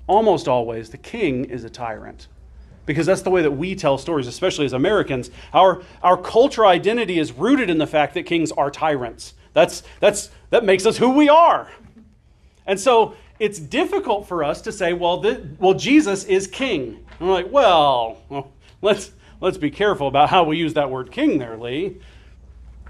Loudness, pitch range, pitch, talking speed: -19 LUFS, 140-200 Hz, 175 Hz, 185 wpm